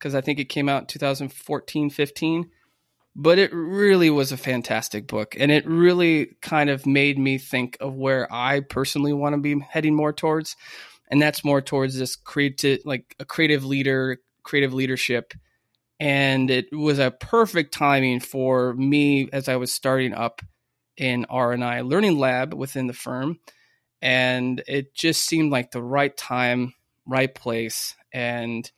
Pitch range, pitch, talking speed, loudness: 125-145 Hz, 135 Hz, 160 wpm, -22 LUFS